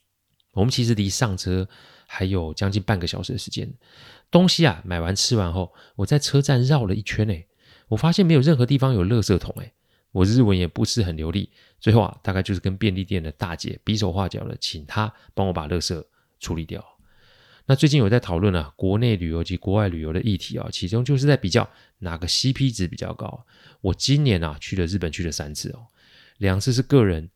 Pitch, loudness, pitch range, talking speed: 105 Hz, -22 LUFS, 95-125 Hz, 310 characters per minute